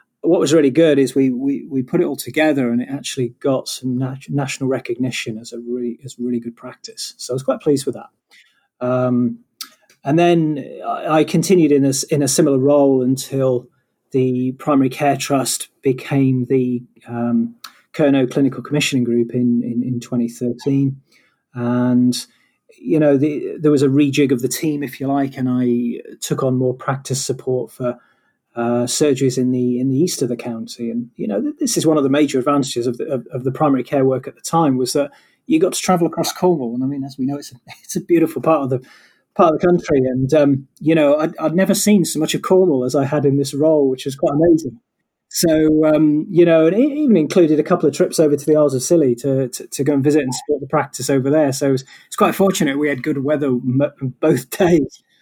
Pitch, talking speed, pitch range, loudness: 140 Hz, 225 wpm, 125-155 Hz, -17 LUFS